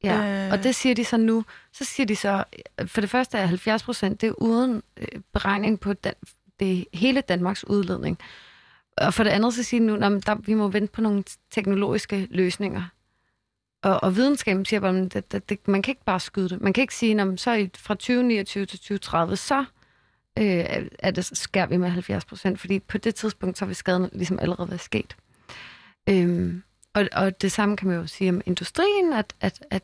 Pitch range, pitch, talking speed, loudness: 185-220 Hz, 200 Hz, 180 wpm, -24 LUFS